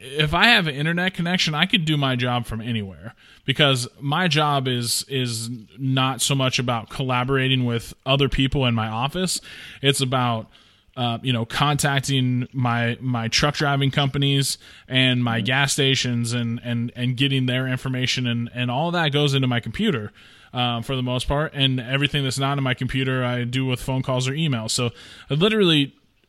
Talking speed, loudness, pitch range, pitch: 185 wpm, -21 LUFS, 120-140 Hz, 130 Hz